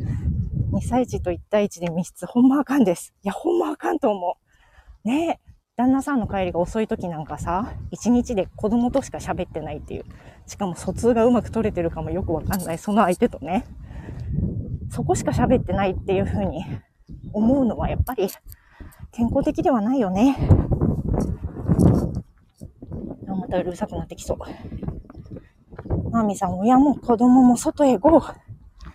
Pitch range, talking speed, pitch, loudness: 185-260 Hz, 310 characters per minute, 225 Hz, -22 LUFS